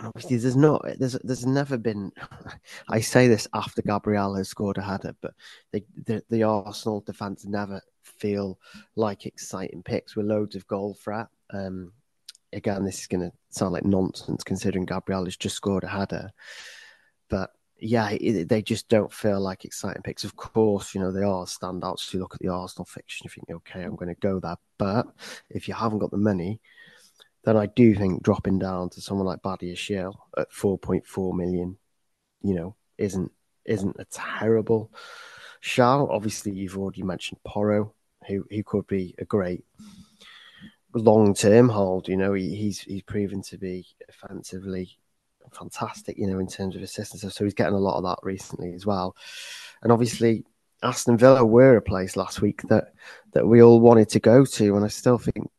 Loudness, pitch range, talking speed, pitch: -24 LUFS, 95-110 Hz, 185 wpm, 100 Hz